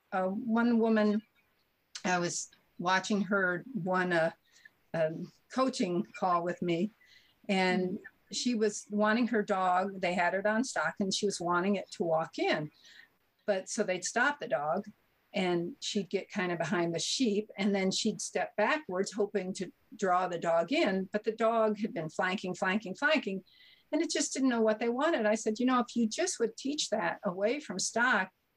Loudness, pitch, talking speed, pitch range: -31 LUFS, 205 Hz, 185 wpm, 185-225 Hz